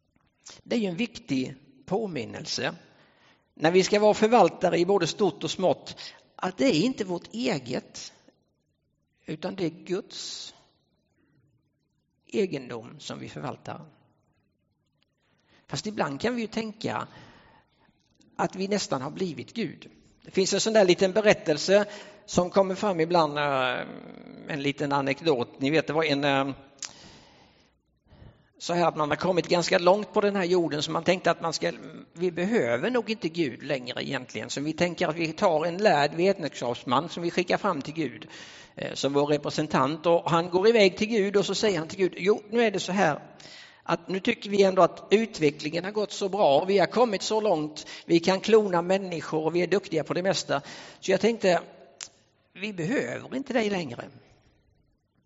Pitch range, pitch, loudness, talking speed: 155-205 Hz, 180 Hz, -26 LUFS, 170 wpm